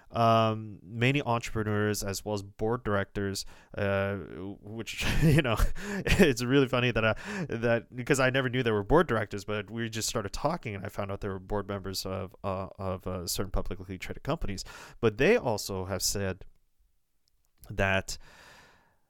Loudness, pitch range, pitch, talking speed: -29 LUFS, 95-115 Hz, 105 Hz, 165 wpm